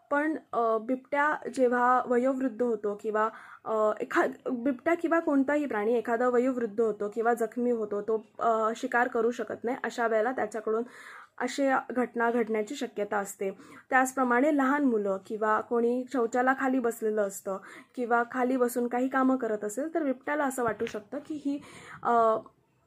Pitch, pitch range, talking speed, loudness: 240 Hz, 220-260 Hz, 140 wpm, -29 LUFS